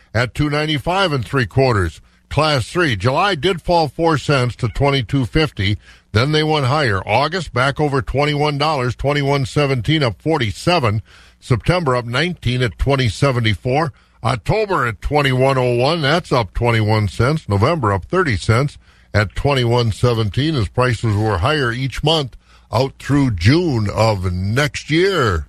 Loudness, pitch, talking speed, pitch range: -17 LUFS, 130 Hz, 125 wpm, 110-150 Hz